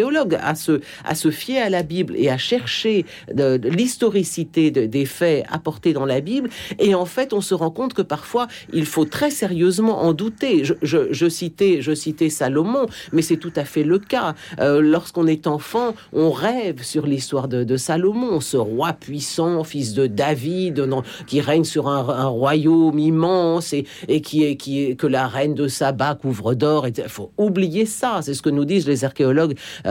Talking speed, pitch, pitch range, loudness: 200 wpm, 160 Hz, 145-185 Hz, -20 LUFS